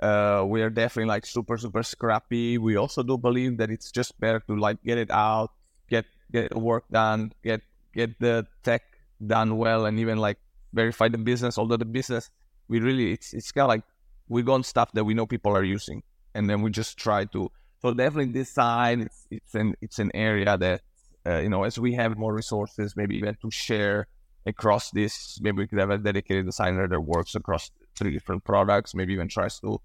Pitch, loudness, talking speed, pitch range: 110 Hz, -26 LUFS, 210 wpm, 105-115 Hz